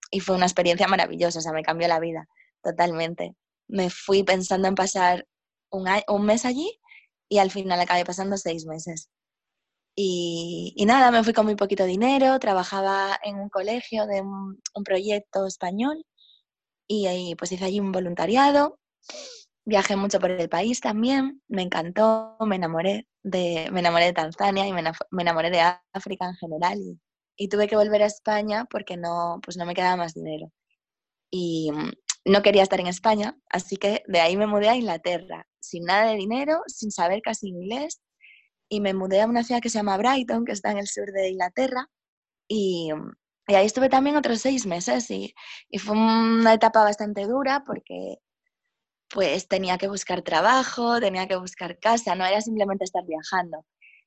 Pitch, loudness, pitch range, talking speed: 195 Hz, -24 LUFS, 175-220 Hz, 180 wpm